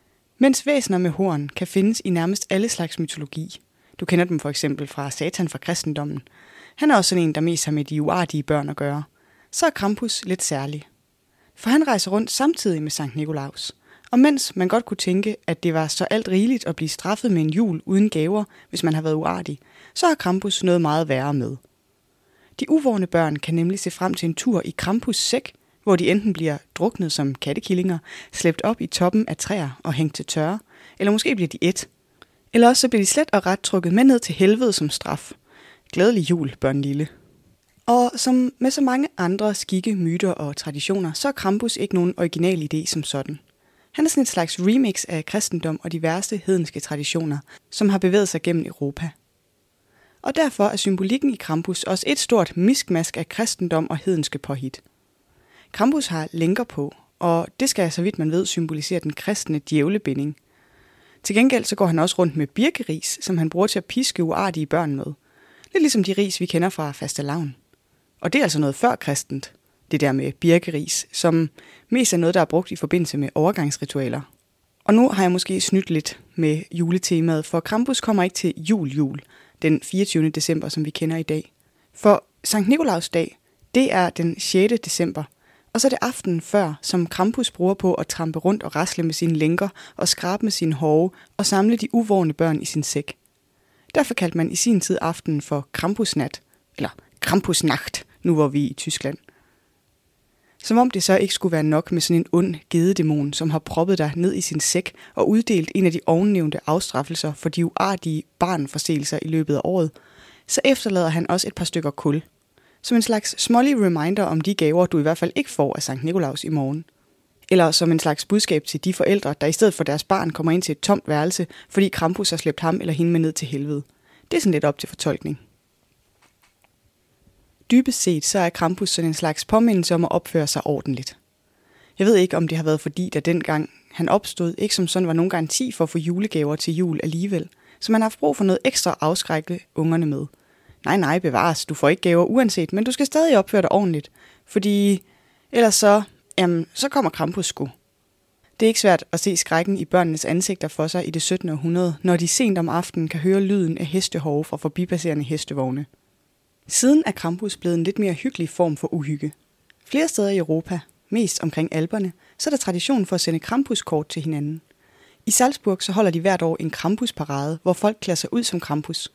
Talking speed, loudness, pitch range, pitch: 205 wpm, -21 LUFS, 155-200 Hz, 170 Hz